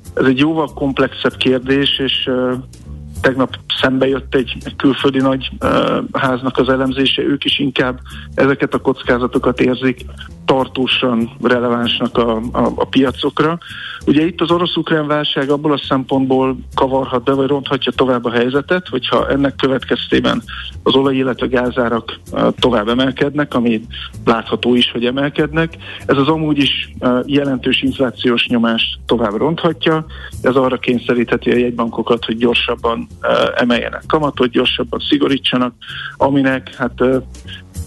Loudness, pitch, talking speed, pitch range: -15 LUFS, 130 Hz, 135 wpm, 120-140 Hz